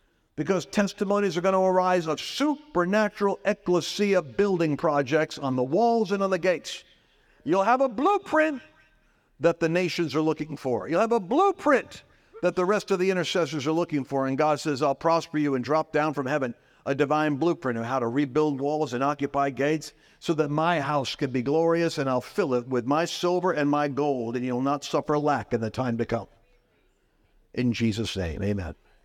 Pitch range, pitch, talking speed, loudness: 140-185 Hz, 155 Hz, 195 wpm, -25 LUFS